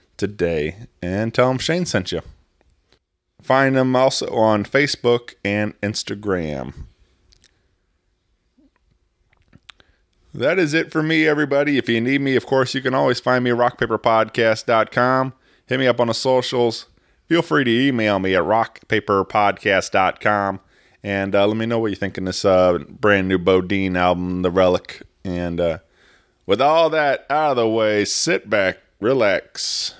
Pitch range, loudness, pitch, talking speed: 95-130 Hz, -19 LUFS, 110 Hz, 150 wpm